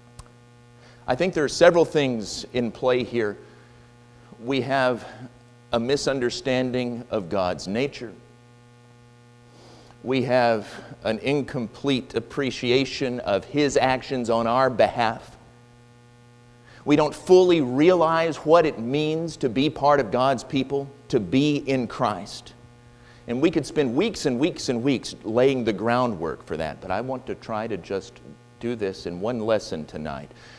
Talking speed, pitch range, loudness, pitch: 140 wpm, 120-135 Hz, -23 LUFS, 120 Hz